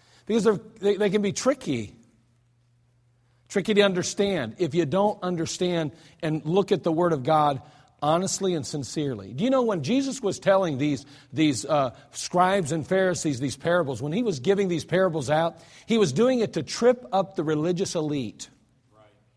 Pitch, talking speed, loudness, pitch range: 165 Hz, 170 wpm, -25 LUFS, 140-195 Hz